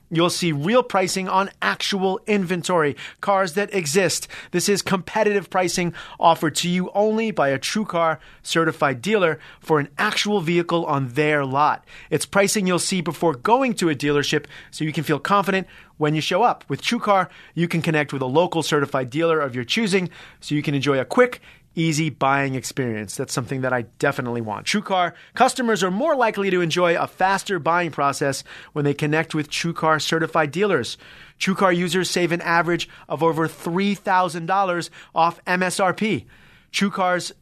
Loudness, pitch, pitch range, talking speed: -21 LUFS, 170 Hz, 150-190 Hz, 170 wpm